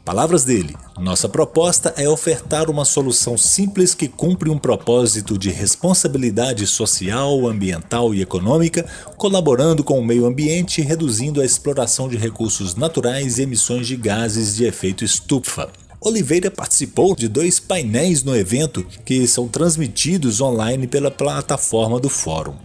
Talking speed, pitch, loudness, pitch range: 140 wpm, 130 Hz, -17 LUFS, 115-155 Hz